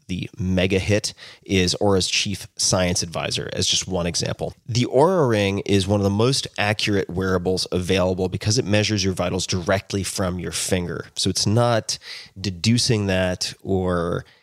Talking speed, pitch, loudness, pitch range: 160 wpm, 95 Hz, -21 LUFS, 90-105 Hz